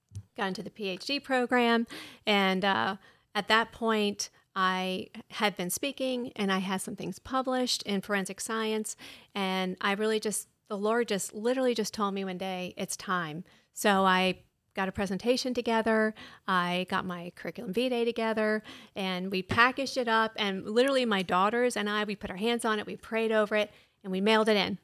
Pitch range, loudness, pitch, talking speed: 190-230 Hz, -29 LUFS, 210 Hz, 185 wpm